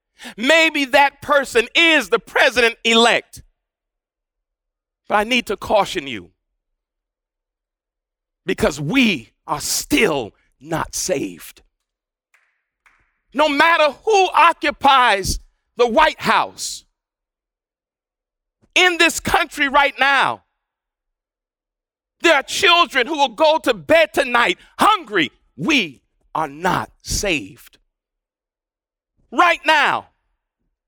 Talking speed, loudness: 90 wpm, -16 LUFS